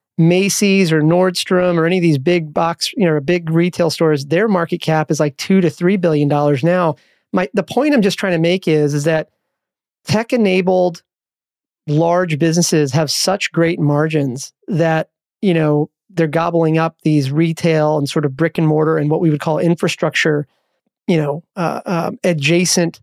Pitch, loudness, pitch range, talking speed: 165 Hz, -16 LUFS, 155-180 Hz, 175 wpm